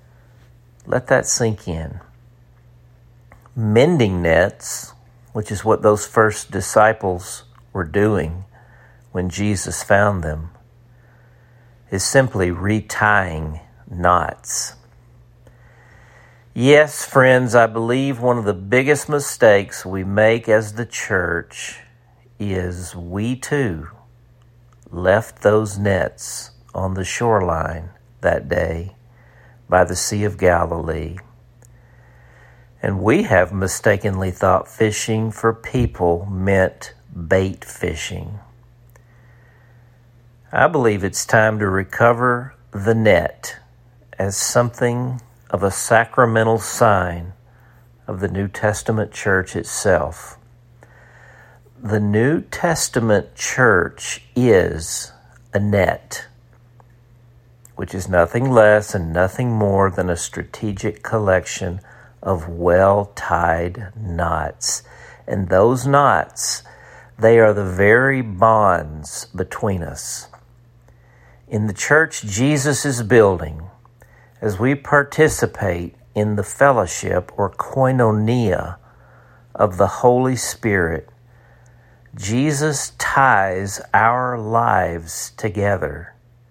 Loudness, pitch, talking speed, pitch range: -18 LUFS, 110 Hz, 95 wpm, 95-120 Hz